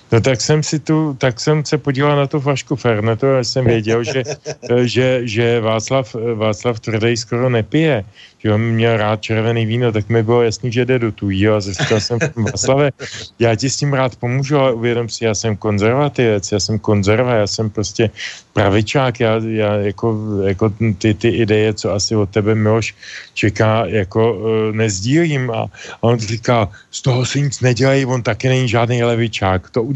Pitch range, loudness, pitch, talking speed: 110-130 Hz, -16 LUFS, 115 Hz, 180 wpm